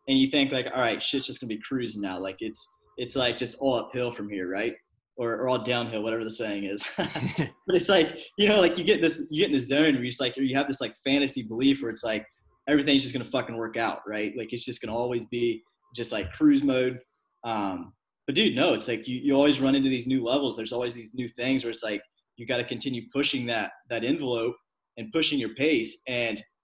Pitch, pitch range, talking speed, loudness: 125 Hz, 115-140 Hz, 250 wpm, -27 LUFS